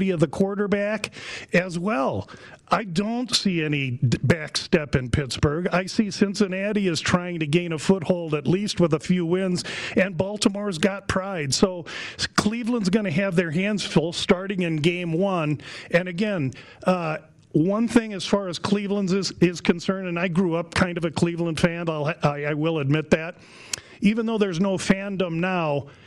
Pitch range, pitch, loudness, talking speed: 165-200 Hz, 180 Hz, -24 LUFS, 175 wpm